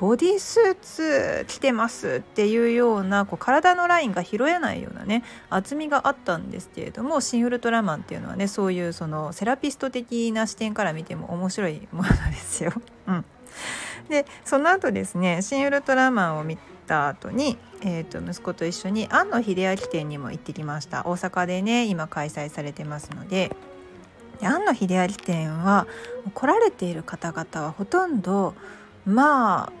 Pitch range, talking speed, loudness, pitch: 170-250 Hz, 345 characters per minute, -24 LUFS, 200 Hz